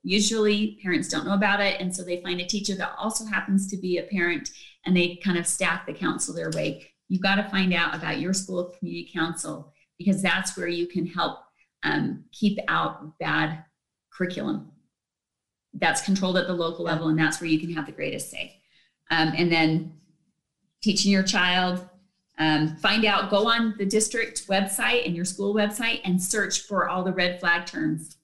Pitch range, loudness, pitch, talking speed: 170-200 Hz, -25 LUFS, 185 Hz, 195 wpm